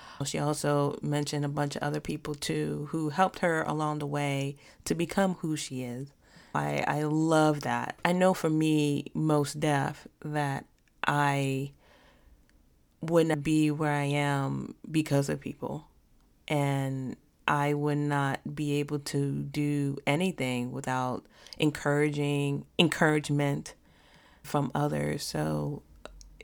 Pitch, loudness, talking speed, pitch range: 145 Hz, -29 LUFS, 125 wpm, 135-150 Hz